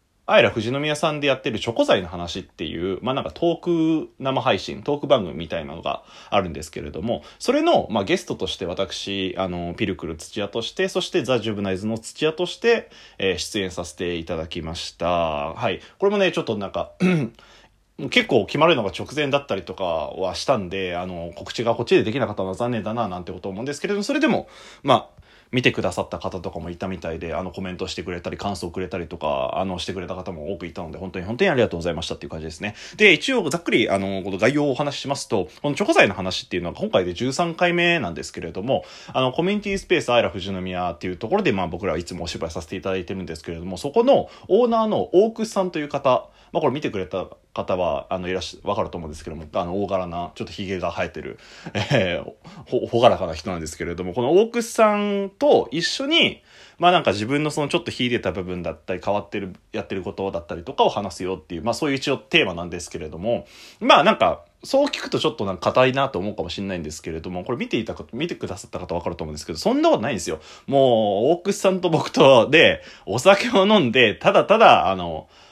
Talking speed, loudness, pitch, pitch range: 490 characters per minute, -22 LUFS, 100 Hz, 90-150 Hz